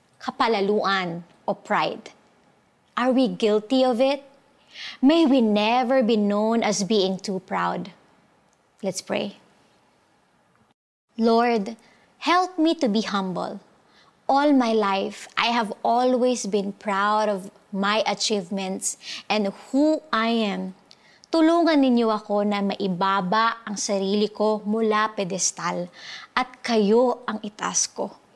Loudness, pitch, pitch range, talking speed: -23 LUFS, 215 Hz, 200-250 Hz, 115 wpm